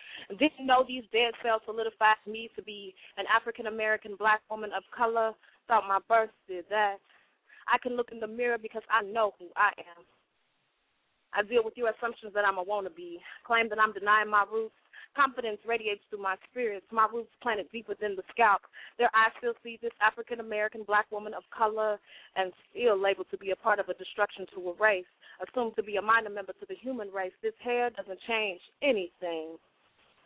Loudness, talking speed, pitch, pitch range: -30 LUFS, 200 wpm, 215 Hz, 200-230 Hz